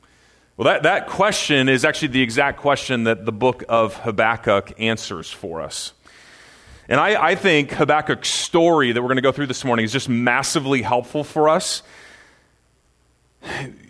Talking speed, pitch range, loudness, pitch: 160 wpm, 115-145 Hz, -19 LUFS, 130 Hz